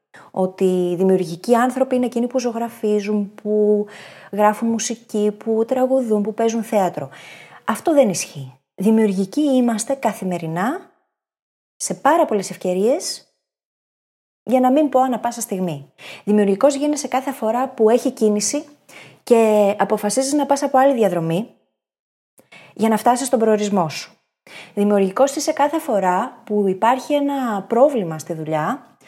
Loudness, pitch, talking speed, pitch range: -19 LUFS, 220 Hz, 130 wpm, 195-260 Hz